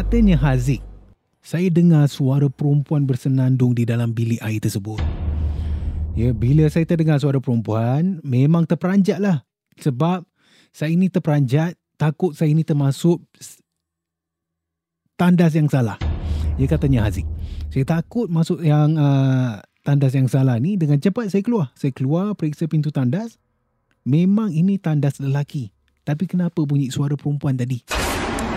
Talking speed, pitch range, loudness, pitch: 130 wpm, 120-165 Hz, -20 LUFS, 145 Hz